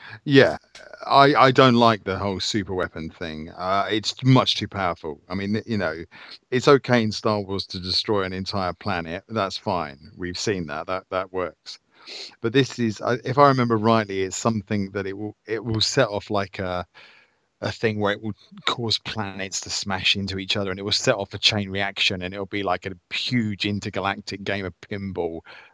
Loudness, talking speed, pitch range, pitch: -23 LUFS, 200 wpm, 95-110 Hz, 100 Hz